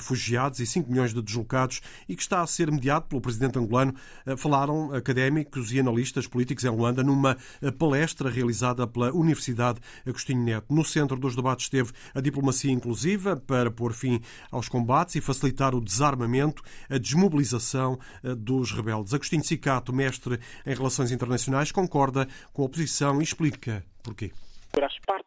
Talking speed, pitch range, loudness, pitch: 150 wpm, 125-145 Hz, -27 LUFS, 130 Hz